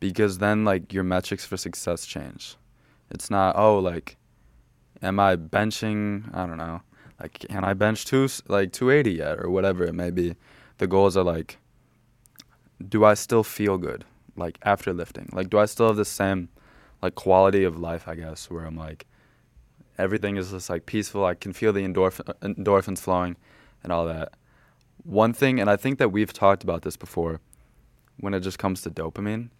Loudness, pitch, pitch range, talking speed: -24 LUFS, 95 Hz, 85-105 Hz, 185 wpm